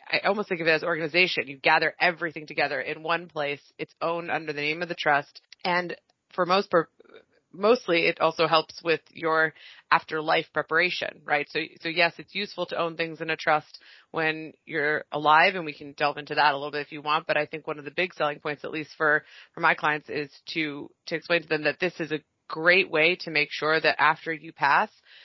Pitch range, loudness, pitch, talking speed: 150-170 Hz, -25 LUFS, 160 Hz, 225 wpm